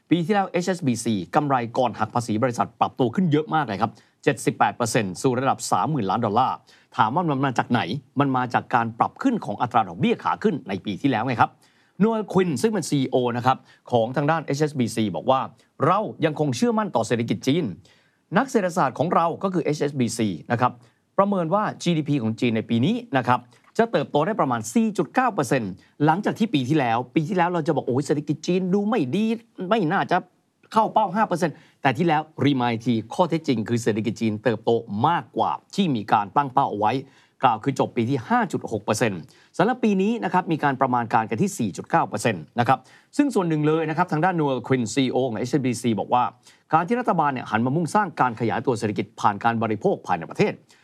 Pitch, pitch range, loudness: 145 Hz, 120-180 Hz, -23 LUFS